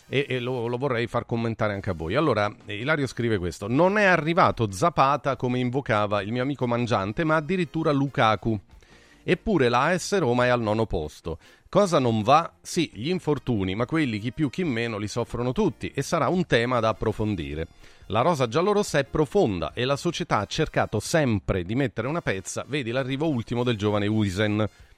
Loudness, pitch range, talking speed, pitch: -25 LUFS, 110-150 Hz, 180 wpm, 125 Hz